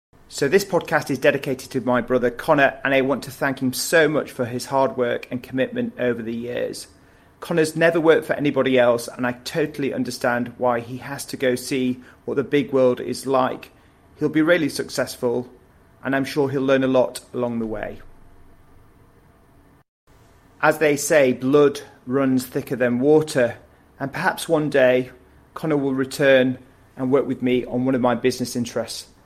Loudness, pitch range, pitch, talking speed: -21 LUFS, 125-140 Hz, 130 Hz, 180 wpm